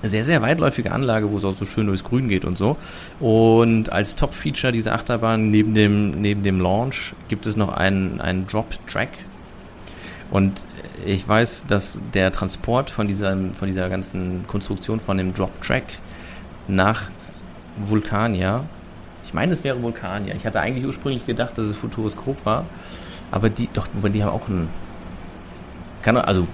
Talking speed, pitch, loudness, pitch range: 160 wpm, 105 Hz, -22 LUFS, 95-115 Hz